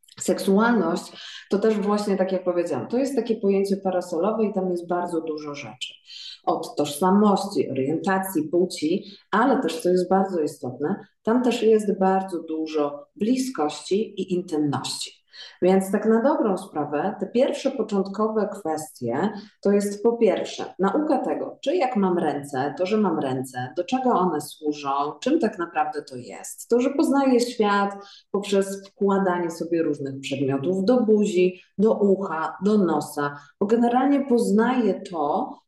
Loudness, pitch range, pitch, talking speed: -23 LUFS, 160-215 Hz, 190 Hz, 145 wpm